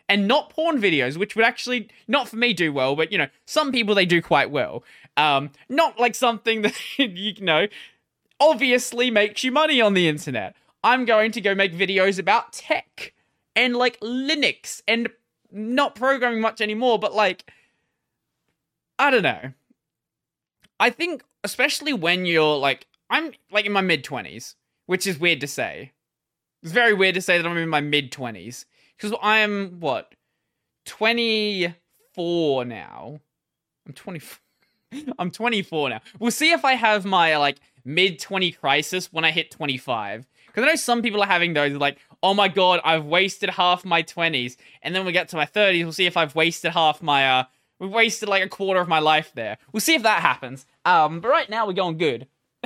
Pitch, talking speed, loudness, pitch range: 195 Hz, 180 wpm, -21 LUFS, 160-230 Hz